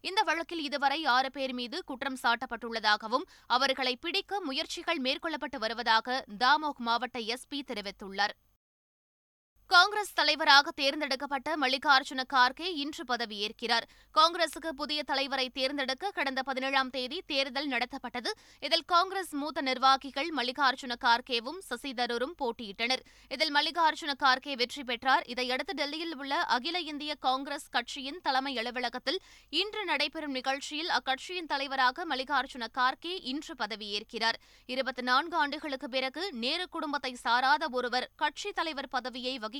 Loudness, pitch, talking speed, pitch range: -30 LUFS, 275 Hz, 110 wpm, 250-305 Hz